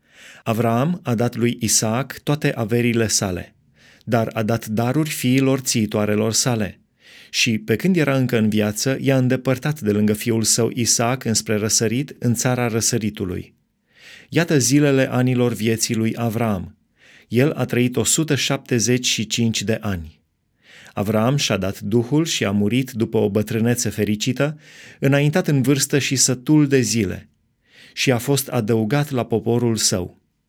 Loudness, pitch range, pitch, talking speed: -19 LUFS, 110-135 Hz, 115 Hz, 140 wpm